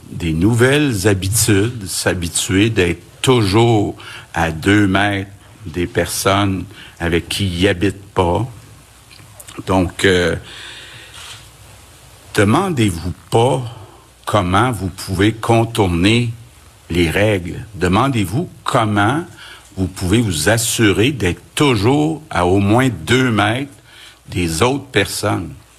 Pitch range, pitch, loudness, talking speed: 95-115 Hz, 105 Hz, -16 LUFS, 100 wpm